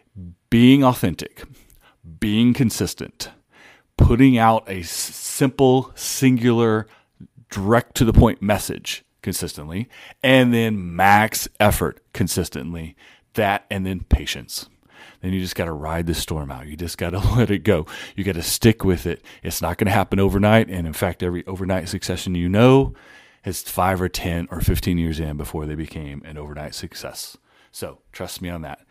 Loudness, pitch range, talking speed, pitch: -20 LUFS, 85-115 Hz, 165 wpm, 95 Hz